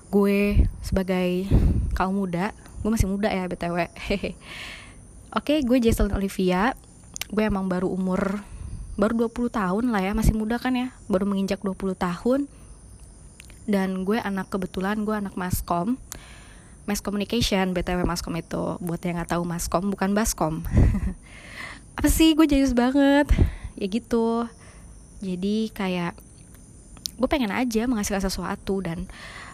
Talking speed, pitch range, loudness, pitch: 130 wpm, 185-230 Hz, -25 LUFS, 200 Hz